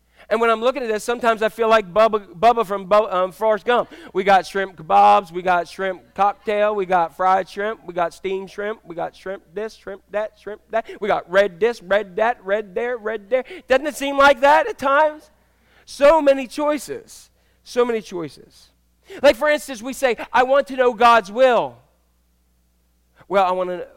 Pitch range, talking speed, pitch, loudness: 190-255 Hz, 200 wpm, 215 Hz, -19 LUFS